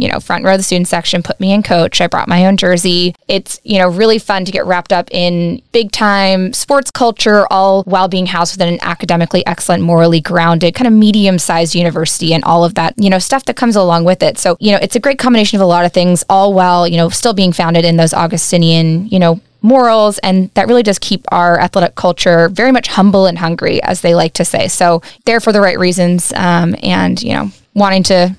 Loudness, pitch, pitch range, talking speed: -11 LUFS, 180 Hz, 170-200 Hz, 235 wpm